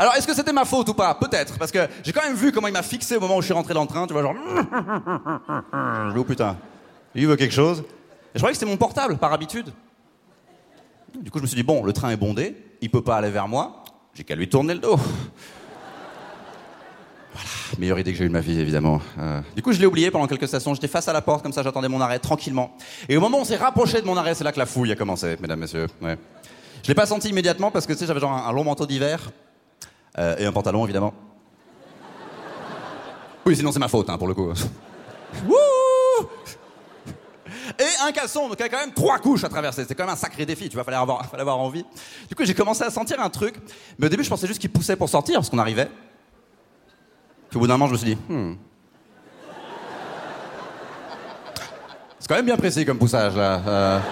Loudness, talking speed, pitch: -22 LUFS, 235 wpm, 145 Hz